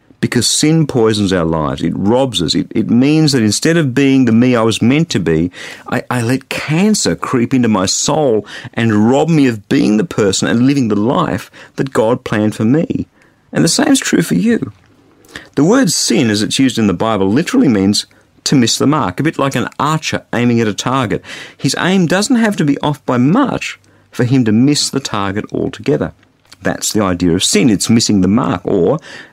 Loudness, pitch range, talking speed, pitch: -13 LUFS, 105-145 Hz, 210 wpm, 120 Hz